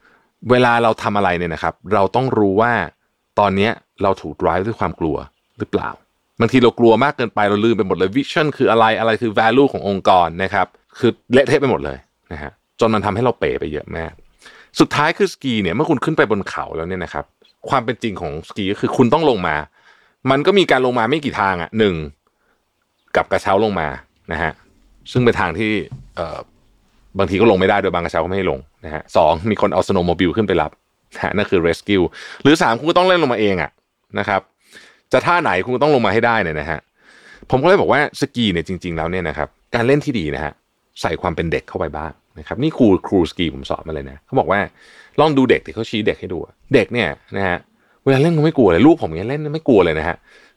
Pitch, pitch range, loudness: 105 Hz, 85-120 Hz, -17 LUFS